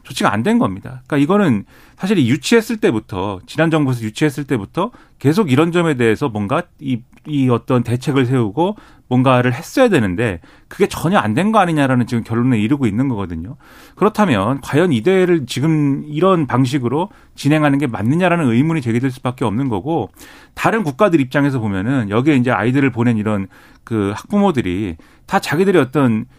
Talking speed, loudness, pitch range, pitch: 390 characters per minute, -16 LUFS, 120-160 Hz, 135 Hz